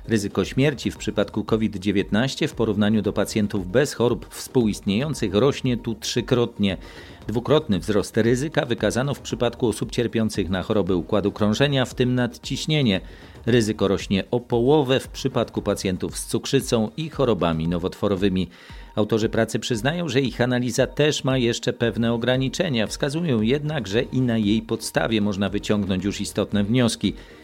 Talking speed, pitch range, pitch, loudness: 140 wpm, 100-125 Hz, 115 Hz, -23 LUFS